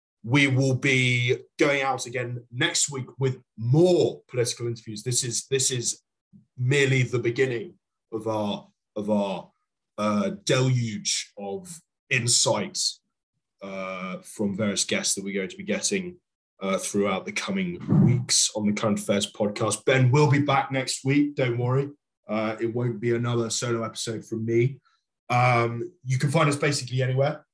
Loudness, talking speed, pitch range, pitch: -25 LUFS, 155 wpm, 115-140 Hz, 125 Hz